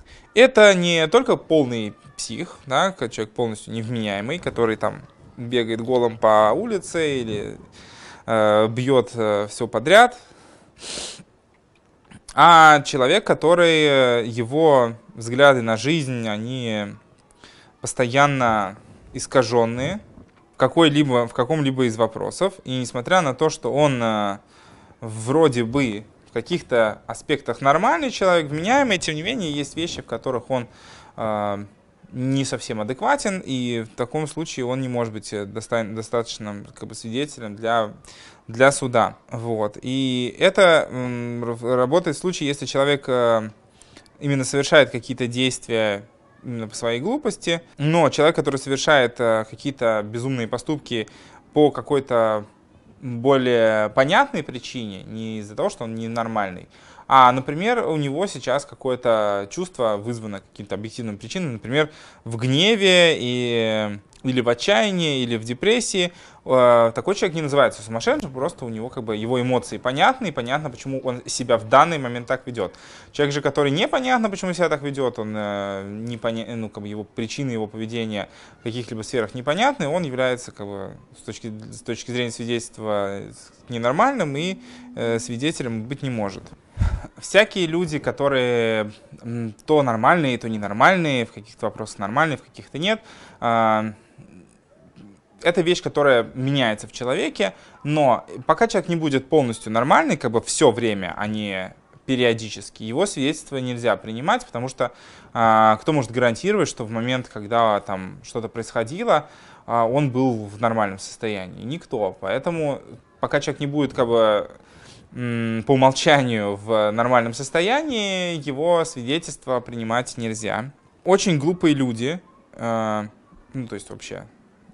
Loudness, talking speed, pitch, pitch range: -21 LUFS, 135 wpm, 125 Hz, 110-145 Hz